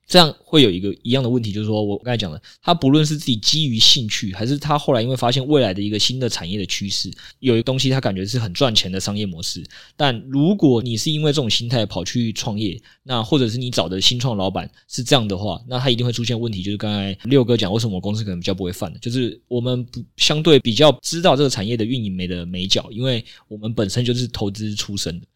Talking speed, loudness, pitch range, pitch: 385 characters per minute, -19 LUFS, 100-130 Hz, 120 Hz